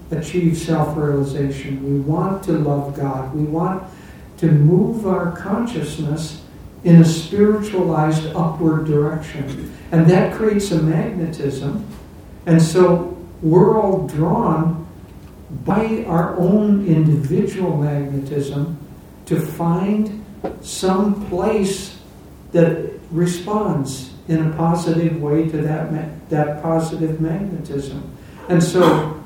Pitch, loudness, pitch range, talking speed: 165 Hz, -18 LUFS, 150-180 Hz, 105 wpm